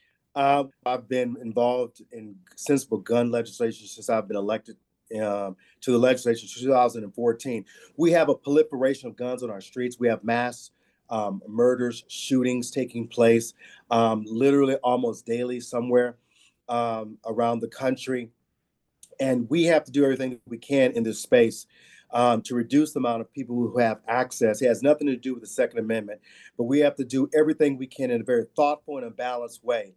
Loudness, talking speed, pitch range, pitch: -25 LUFS, 180 wpm, 115-135 Hz, 120 Hz